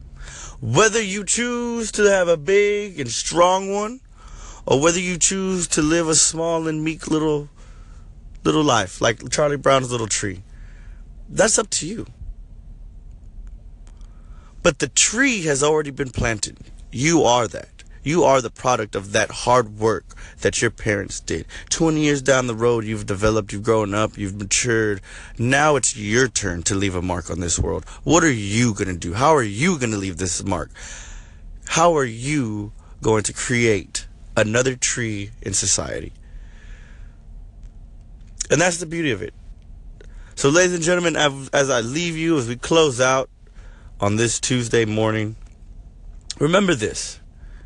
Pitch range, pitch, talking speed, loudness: 95-150 Hz, 110 Hz, 155 wpm, -20 LUFS